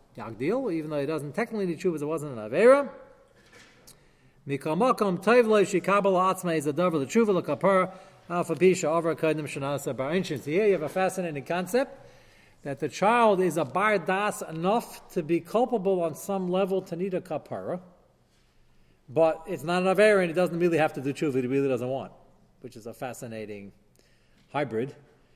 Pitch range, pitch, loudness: 145-195 Hz, 175 Hz, -26 LUFS